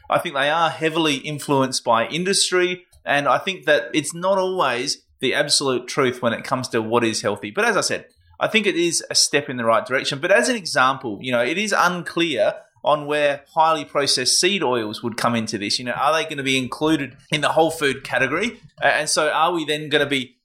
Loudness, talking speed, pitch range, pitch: -20 LUFS, 230 wpm, 125-165 Hz, 145 Hz